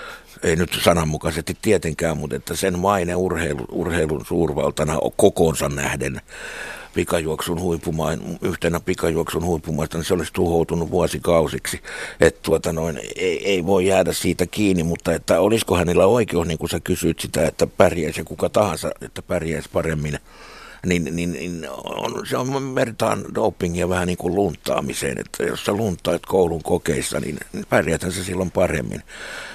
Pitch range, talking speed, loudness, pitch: 80-90 Hz, 150 wpm, -21 LUFS, 85 Hz